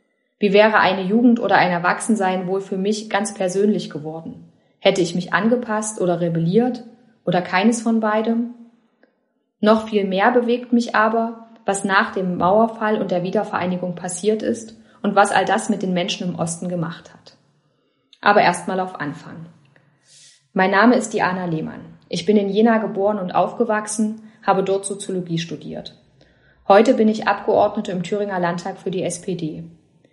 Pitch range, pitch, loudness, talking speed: 180-220 Hz, 195 Hz, -19 LUFS, 155 wpm